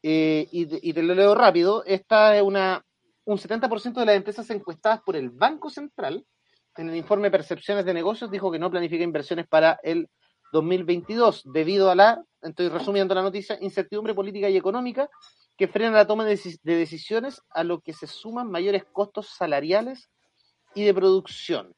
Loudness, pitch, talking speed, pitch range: -23 LUFS, 195 Hz, 170 wpm, 170-215 Hz